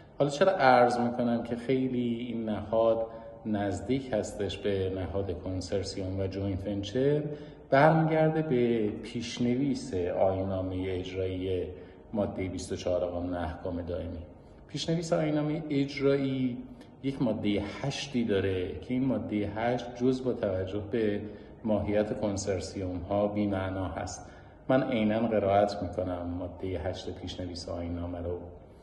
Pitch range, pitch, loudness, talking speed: 95-125 Hz, 105 Hz, -30 LUFS, 115 wpm